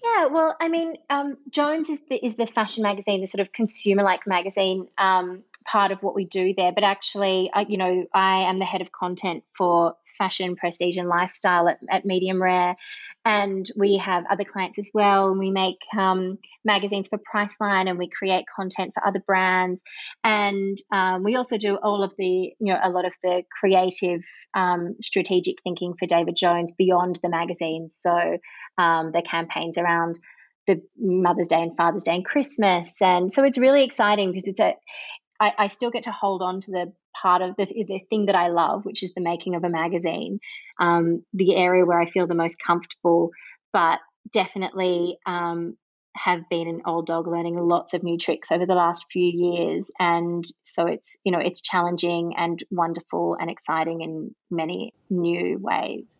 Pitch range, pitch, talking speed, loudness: 175-200 Hz, 185 Hz, 185 wpm, -23 LUFS